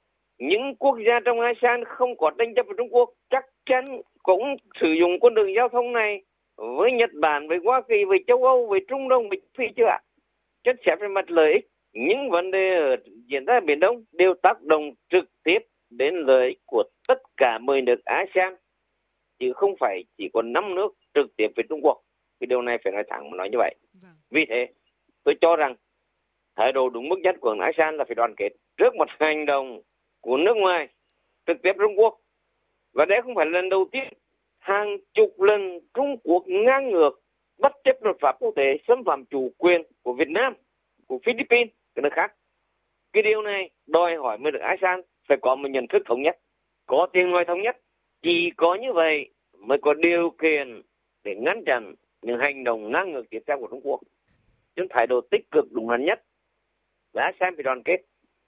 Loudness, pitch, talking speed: -23 LUFS, 215 Hz, 205 wpm